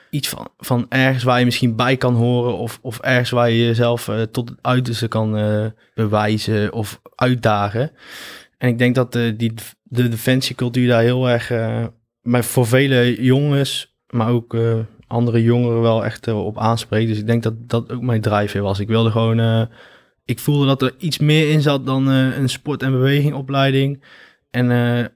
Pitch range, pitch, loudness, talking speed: 115-130 Hz, 120 Hz, -18 LUFS, 190 wpm